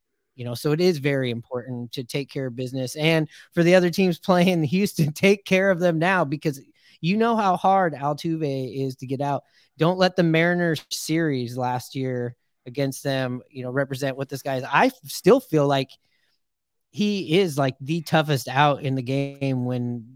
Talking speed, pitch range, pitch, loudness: 195 wpm, 130-170 Hz, 145 Hz, -23 LUFS